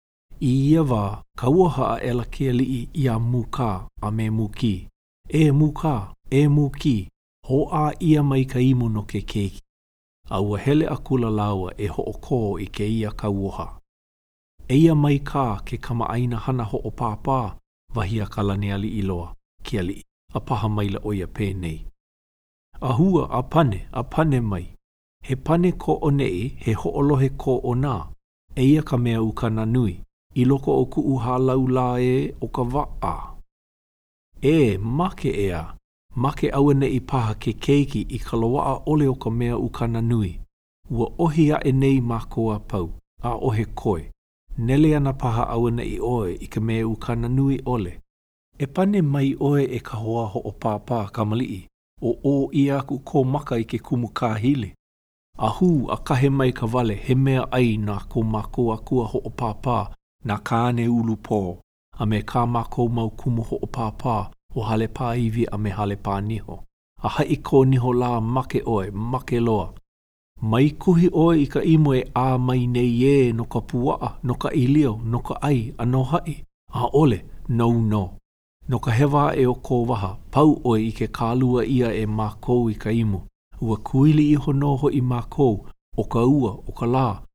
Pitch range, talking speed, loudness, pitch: 105-135 Hz, 185 wpm, -22 LUFS, 120 Hz